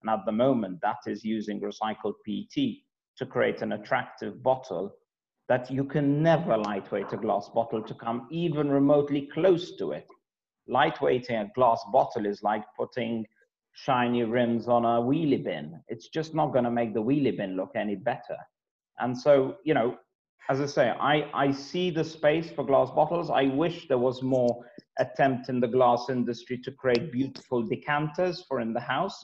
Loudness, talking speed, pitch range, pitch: -27 LUFS, 180 wpm, 120-150 Hz, 130 Hz